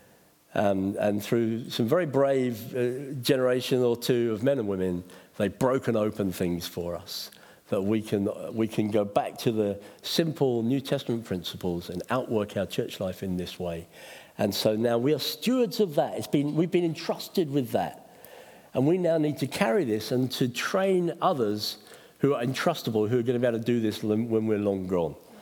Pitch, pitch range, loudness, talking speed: 120 Hz, 105-140 Hz, -27 LUFS, 195 wpm